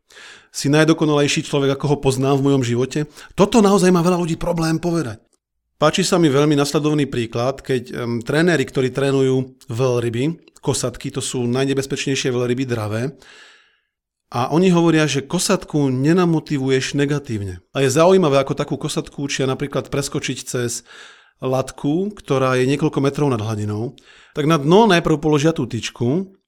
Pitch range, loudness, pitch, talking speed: 130-165 Hz, -18 LUFS, 145 Hz, 145 wpm